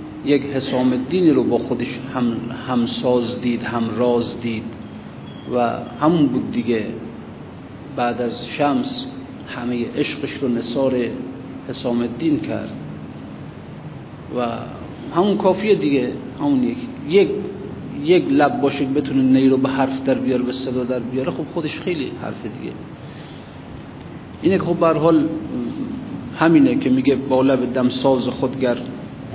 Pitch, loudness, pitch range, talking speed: 130 Hz, -20 LUFS, 120-145 Hz, 130 wpm